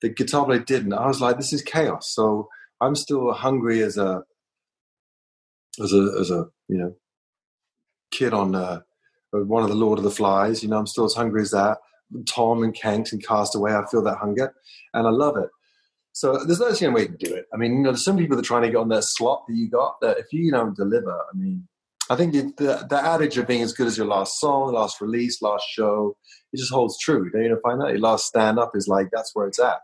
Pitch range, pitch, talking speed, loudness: 105-135 Hz, 115 Hz, 250 wpm, -22 LUFS